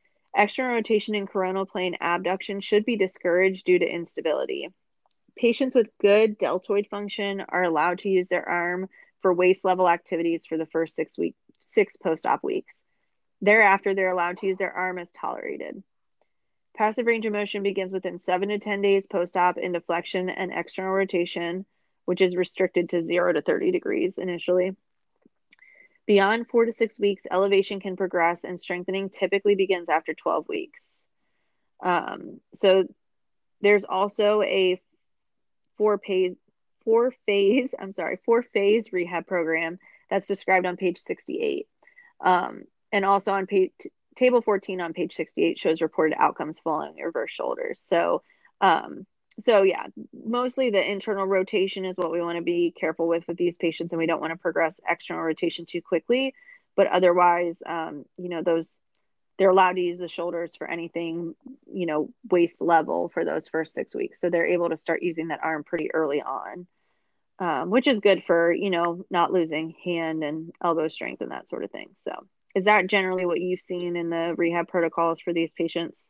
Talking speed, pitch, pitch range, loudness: 170 wpm, 185 Hz, 170-205 Hz, -25 LUFS